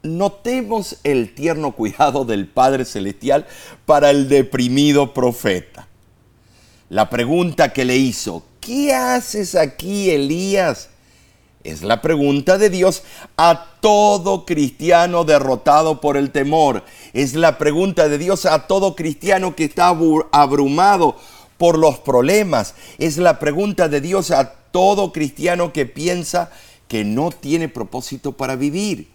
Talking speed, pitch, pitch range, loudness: 130 wpm, 150 Hz, 135-175 Hz, -16 LUFS